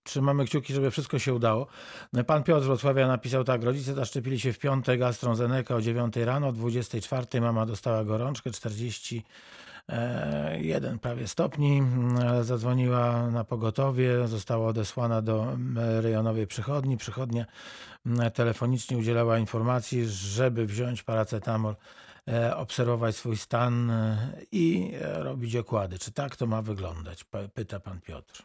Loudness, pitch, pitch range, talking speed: -28 LUFS, 120 Hz, 115-130 Hz, 120 wpm